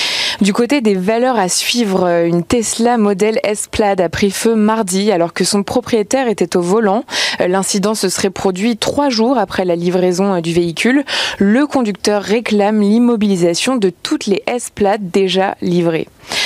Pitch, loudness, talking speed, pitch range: 205 Hz, -14 LUFS, 155 wpm, 190-240 Hz